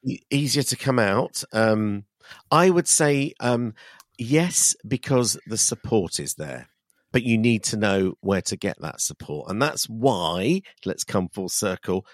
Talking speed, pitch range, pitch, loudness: 160 wpm, 100-140 Hz, 120 Hz, -23 LUFS